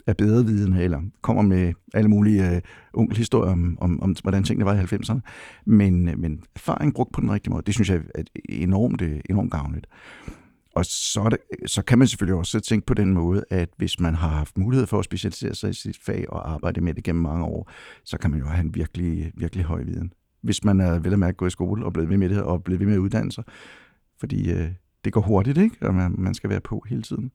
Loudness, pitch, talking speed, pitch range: -23 LUFS, 95 Hz, 240 wpm, 85-110 Hz